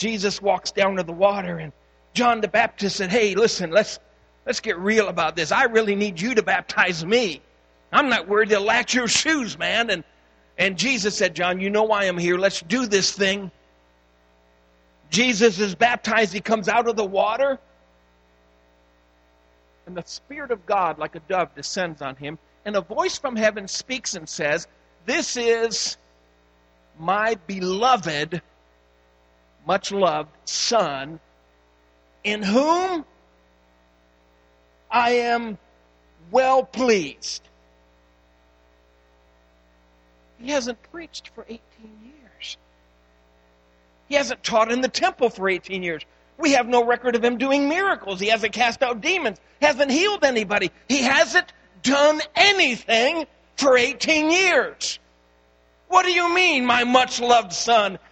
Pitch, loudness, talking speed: 195 Hz, -21 LUFS, 140 wpm